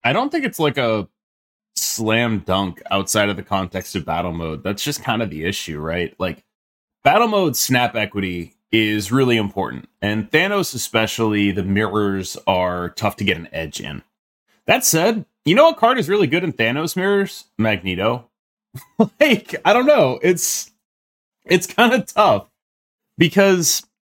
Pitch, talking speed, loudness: 115 Hz, 160 wpm, -18 LUFS